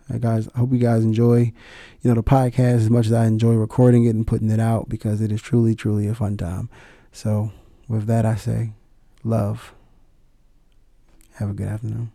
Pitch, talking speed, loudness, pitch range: 115 Hz, 200 wpm, -20 LUFS, 110-120 Hz